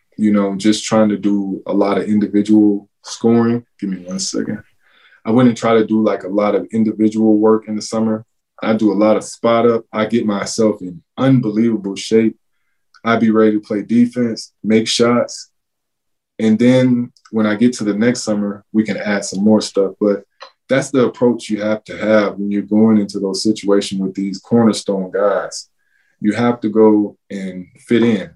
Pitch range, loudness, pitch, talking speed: 100-115 Hz, -16 LUFS, 110 Hz, 190 wpm